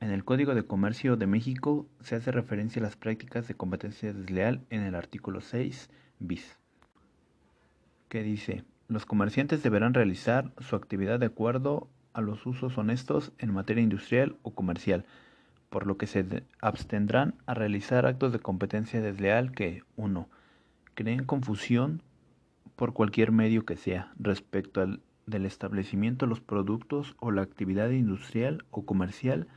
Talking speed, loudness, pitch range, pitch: 150 wpm, -30 LUFS, 100-125 Hz, 110 Hz